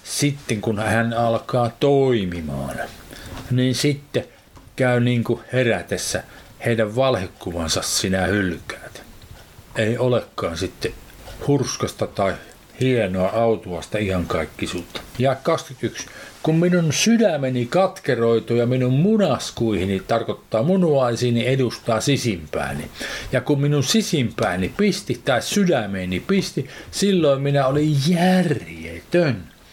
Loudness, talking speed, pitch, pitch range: -21 LUFS, 100 wpm, 125 Hz, 110-145 Hz